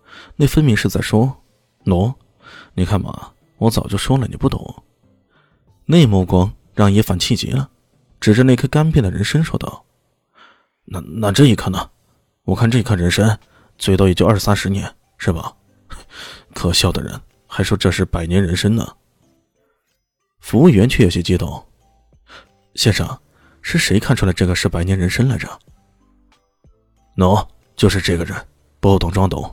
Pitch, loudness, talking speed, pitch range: 100 Hz, -16 LUFS, 230 characters per minute, 95-120 Hz